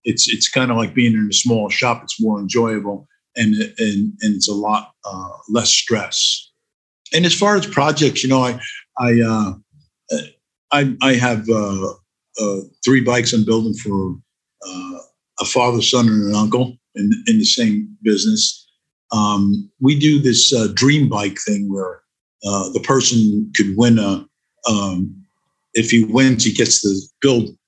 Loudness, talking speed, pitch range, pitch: -16 LUFS, 165 wpm, 105-140 Hz, 115 Hz